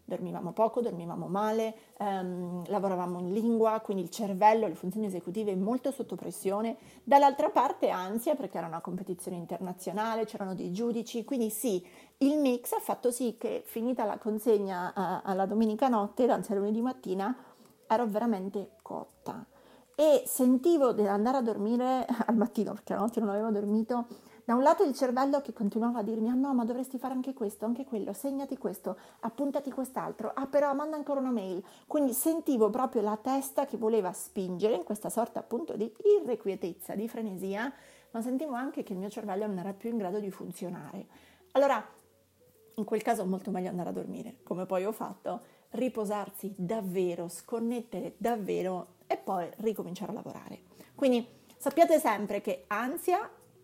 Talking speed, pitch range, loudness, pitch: 165 wpm, 200-255 Hz, -31 LUFS, 220 Hz